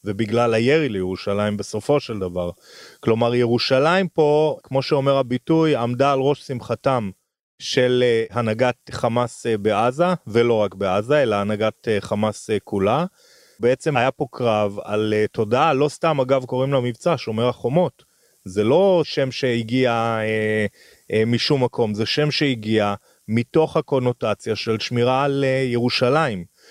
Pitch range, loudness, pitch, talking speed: 110-135 Hz, -20 LUFS, 120 Hz, 130 wpm